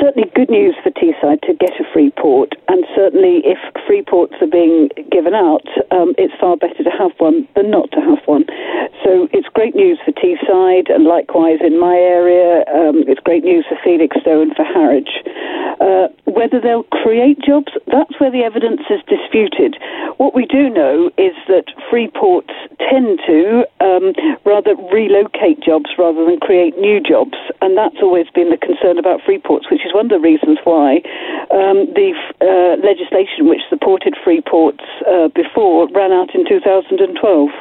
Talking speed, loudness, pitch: 170 wpm, -12 LUFS, 285 Hz